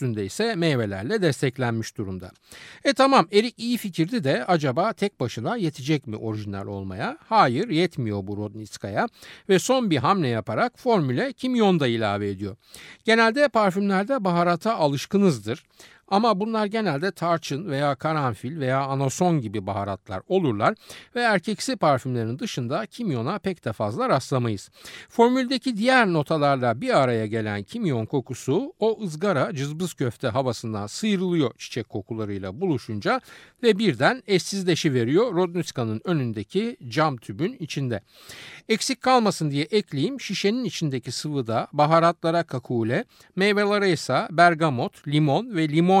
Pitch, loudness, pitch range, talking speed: 155 Hz, -24 LUFS, 120-200 Hz, 125 wpm